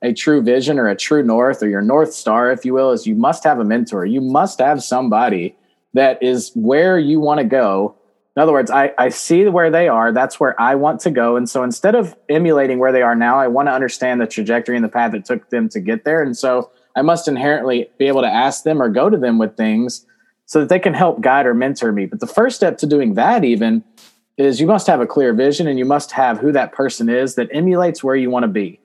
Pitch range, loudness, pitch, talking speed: 125-170 Hz, -15 LUFS, 135 Hz, 260 wpm